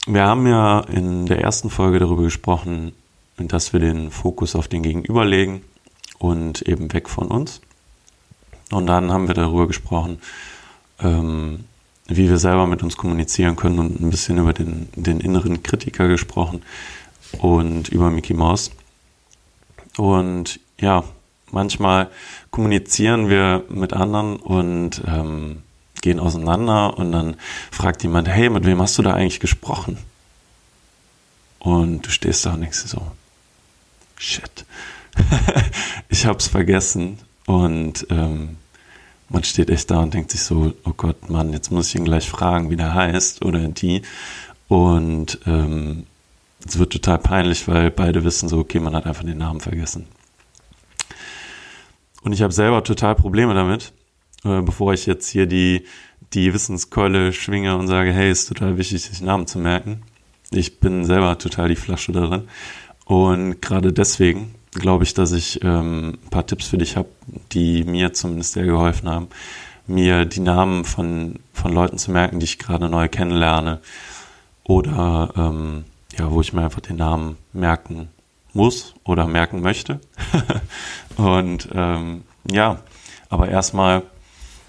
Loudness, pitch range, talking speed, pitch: -19 LUFS, 85-95 Hz, 150 wpm, 90 Hz